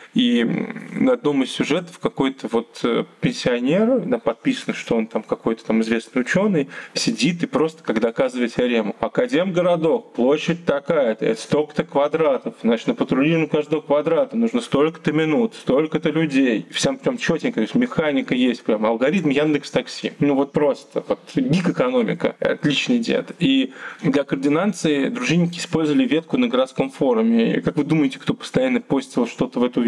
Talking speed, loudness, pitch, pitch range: 160 wpm, -20 LUFS, 170 Hz, 145-245 Hz